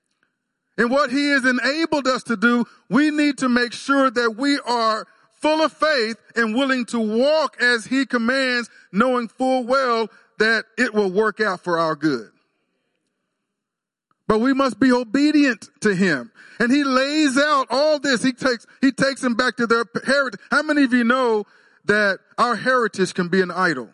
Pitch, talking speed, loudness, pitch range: 250 Hz, 180 wpm, -19 LUFS, 225-275 Hz